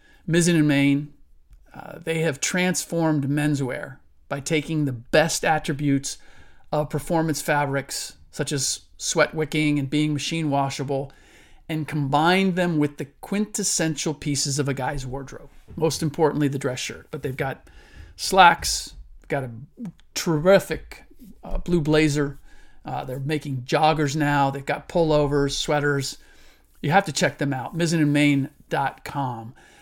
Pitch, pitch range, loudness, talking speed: 150 Hz, 140-160 Hz, -23 LUFS, 135 wpm